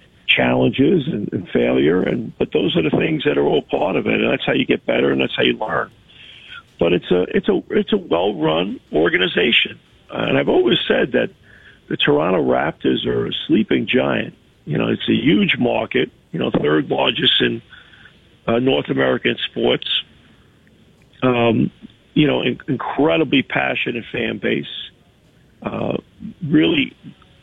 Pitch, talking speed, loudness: 130 Hz, 160 wpm, -18 LUFS